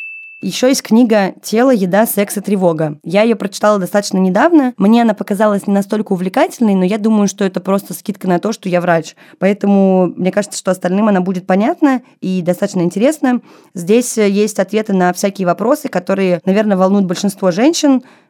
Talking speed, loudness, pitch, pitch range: 175 wpm, -14 LUFS, 200 Hz, 185-225 Hz